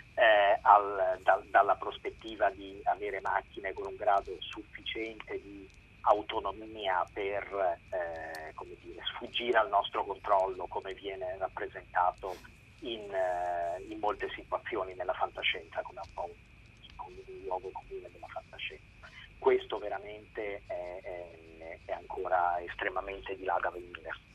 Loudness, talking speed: -33 LUFS, 130 wpm